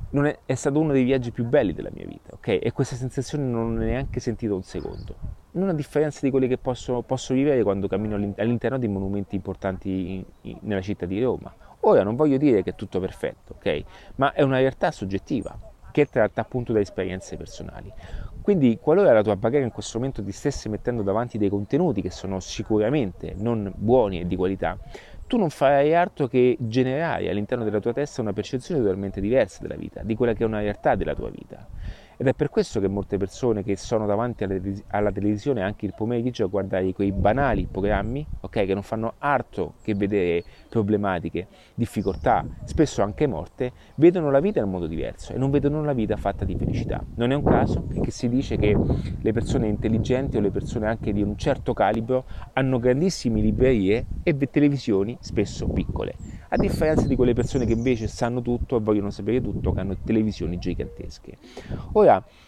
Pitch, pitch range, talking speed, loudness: 110 Hz, 100-130 Hz, 190 wpm, -24 LUFS